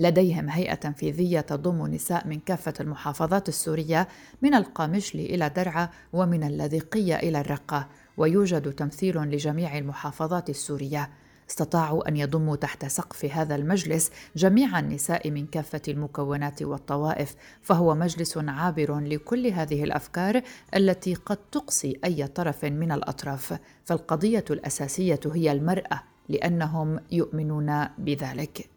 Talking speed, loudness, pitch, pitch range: 115 wpm, -27 LUFS, 160 Hz, 145-175 Hz